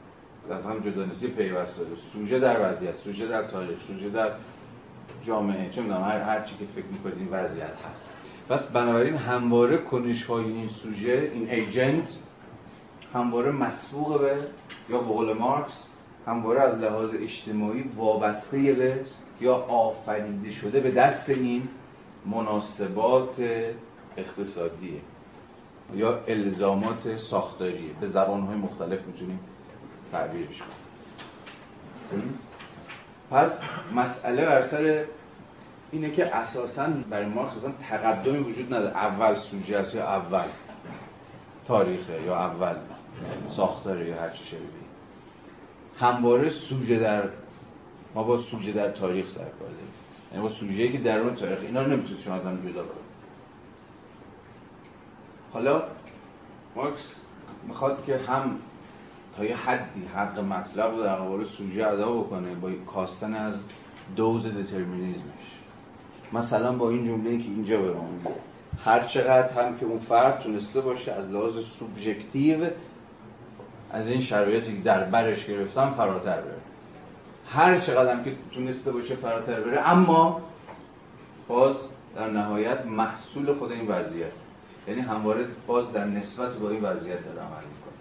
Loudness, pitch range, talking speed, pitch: -27 LUFS, 105-125 Hz, 125 wpm, 115 Hz